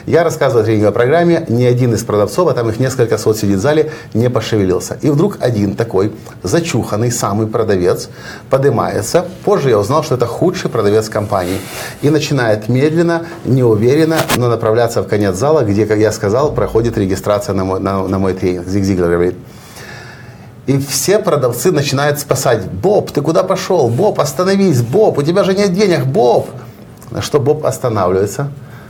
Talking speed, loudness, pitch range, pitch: 165 wpm, -14 LUFS, 105-150 Hz, 120 Hz